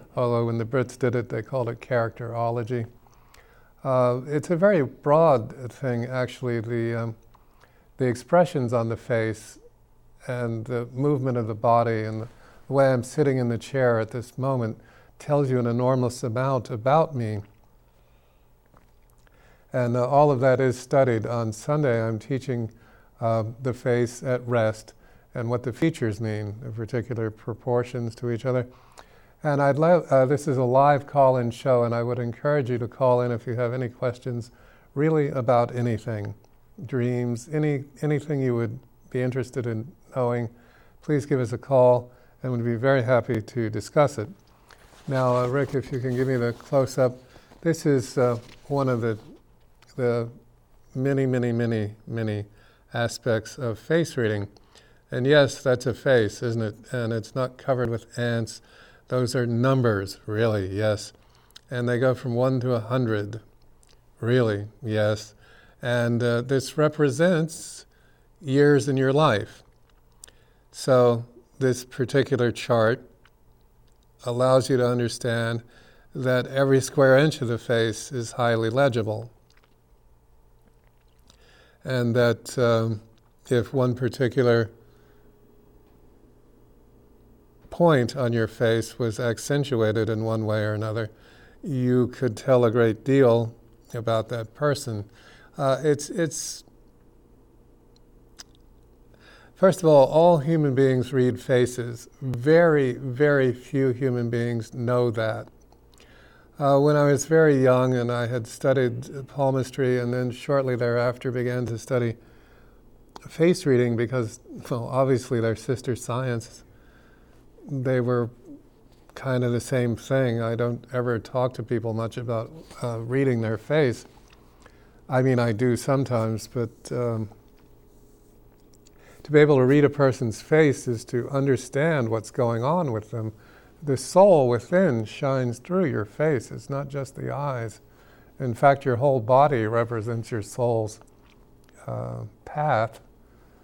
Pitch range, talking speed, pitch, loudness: 115-130 Hz, 140 wpm, 120 Hz, -24 LUFS